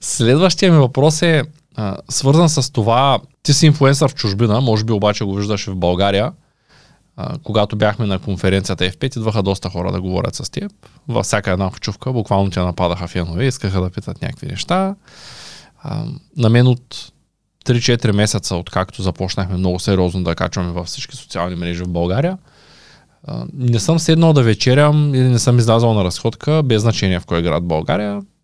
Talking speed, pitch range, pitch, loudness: 175 wpm, 95-135 Hz, 110 Hz, -16 LUFS